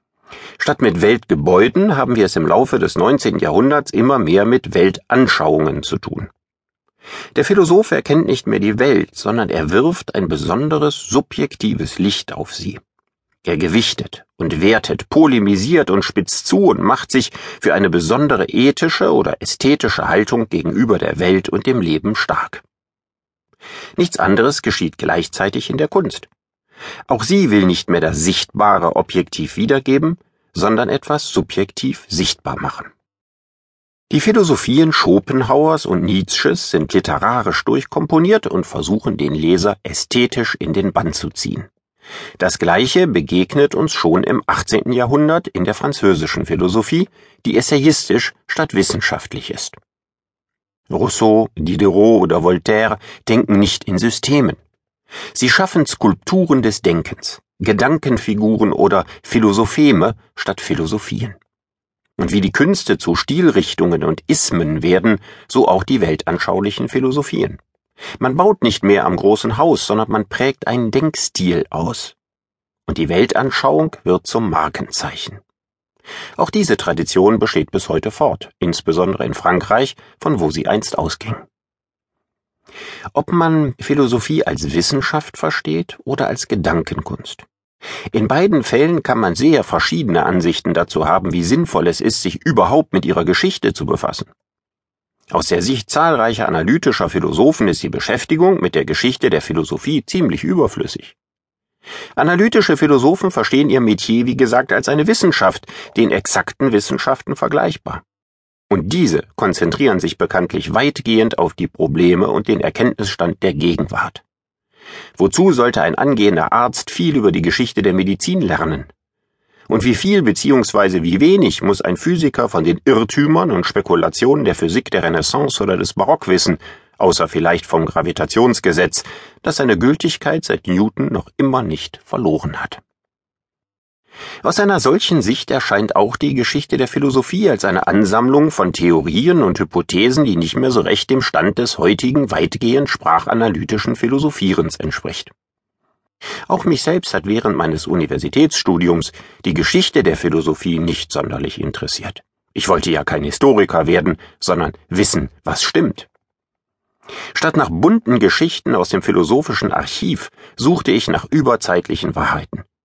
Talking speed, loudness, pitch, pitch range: 135 wpm, -15 LUFS, 115 Hz, 100-150 Hz